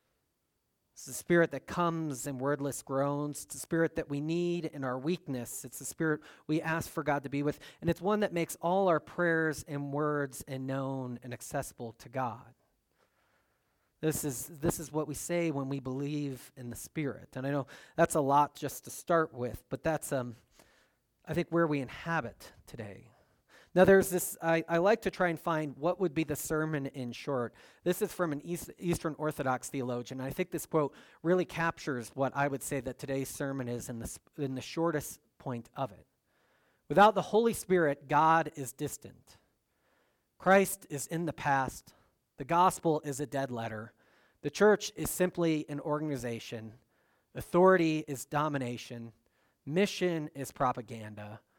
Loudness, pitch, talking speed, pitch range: -32 LUFS, 145 Hz, 180 wpm, 130-165 Hz